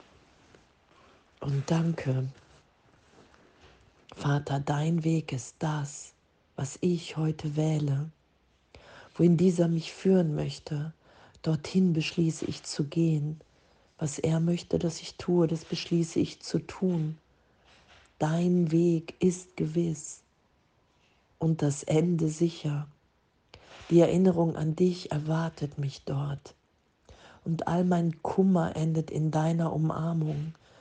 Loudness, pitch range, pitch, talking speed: -29 LUFS, 145-170 Hz, 160 Hz, 105 wpm